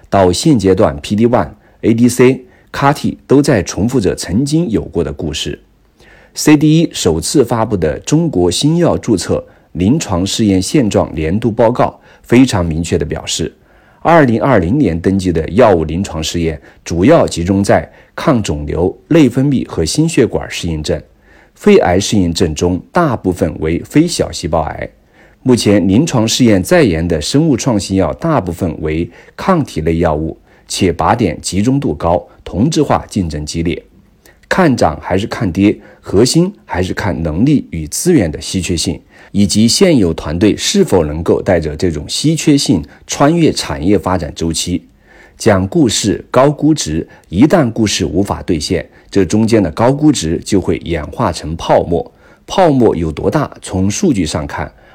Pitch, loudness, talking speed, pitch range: 95 Hz, -13 LUFS, 245 characters per minute, 85-120 Hz